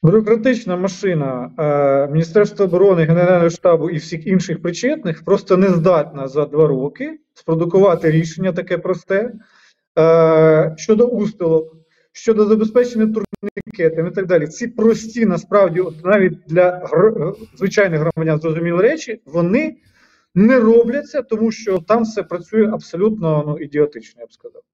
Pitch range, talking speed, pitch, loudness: 160-220 Hz, 135 wpm, 185 Hz, -16 LUFS